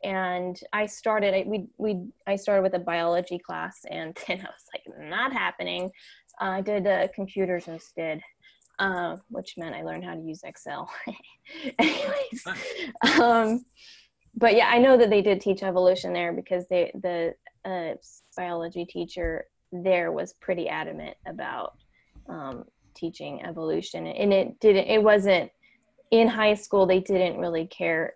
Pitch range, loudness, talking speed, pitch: 175-225 Hz, -25 LUFS, 155 wpm, 195 Hz